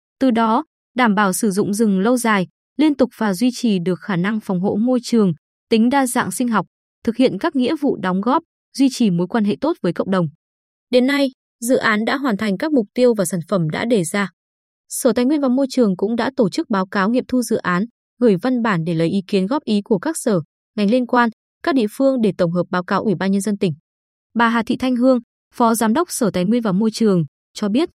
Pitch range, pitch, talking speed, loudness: 195-250 Hz, 230 Hz, 255 wpm, -18 LUFS